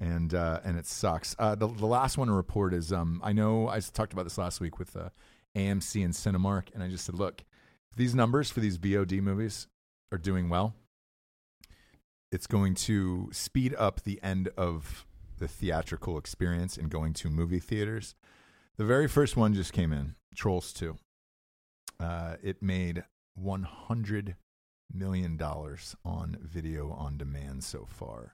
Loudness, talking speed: -32 LUFS, 165 wpm